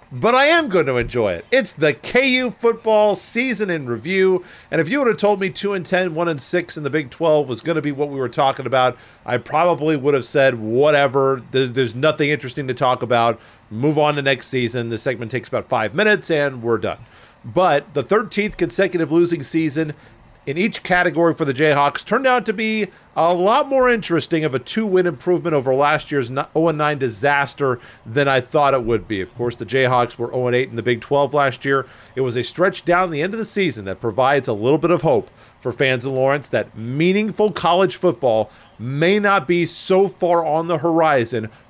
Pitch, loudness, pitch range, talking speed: 150 Hz, -18 LUFS, 130-180 Hz, 215 wpm